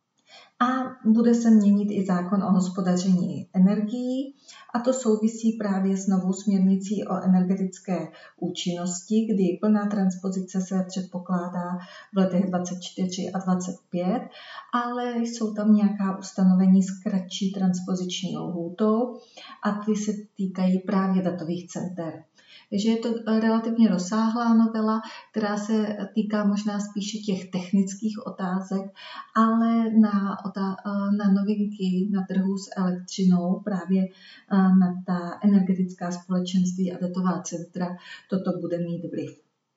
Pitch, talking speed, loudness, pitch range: 195 Hz, 120 wpm, -25 LUFS, 185-215 Hz